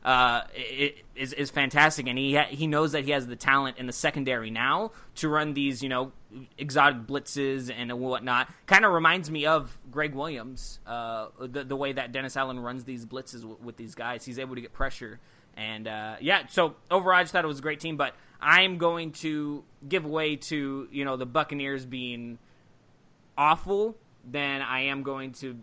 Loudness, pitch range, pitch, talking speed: -27 LUFS, 125-150 Hz, 135 Hz, 200 wpm